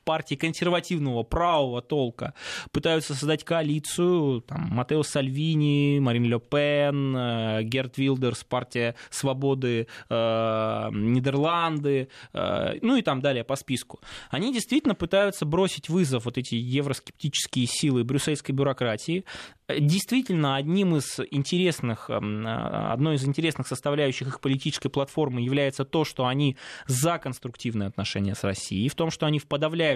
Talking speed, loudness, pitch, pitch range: 130 wpm, -26 LUFS, 140 Hz, 125-160 Hz